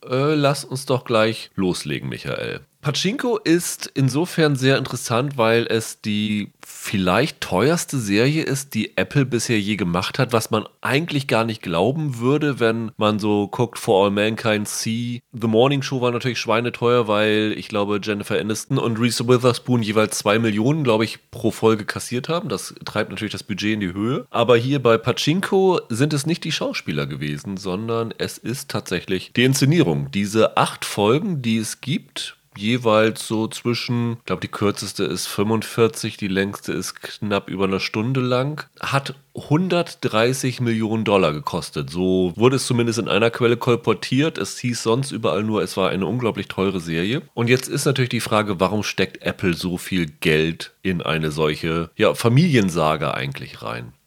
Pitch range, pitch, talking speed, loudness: 105-130 Hz, 115 Hz, 170 wpm, -21 LUFS